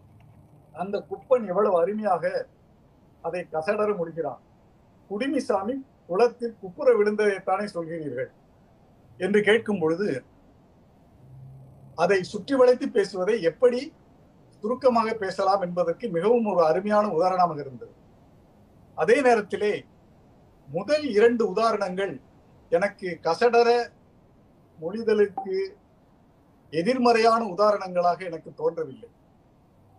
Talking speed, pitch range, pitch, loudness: 80 wpm, 175-240 Hz, 205 Hz, -24 LUFS